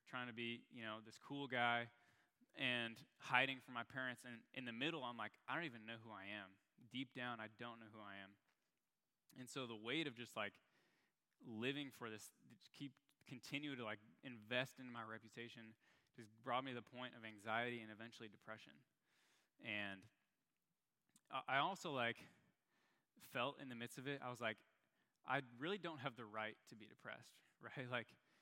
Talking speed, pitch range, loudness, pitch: 185 wpm, 110-130 Hz, -48 LUFS, 120 Hz